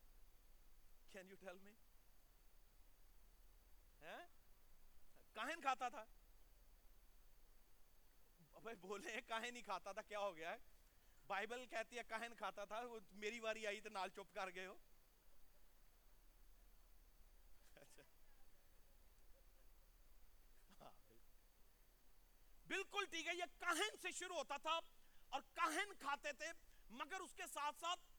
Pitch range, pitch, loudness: 200-330 Hz, 235 Hz, -49 LUFS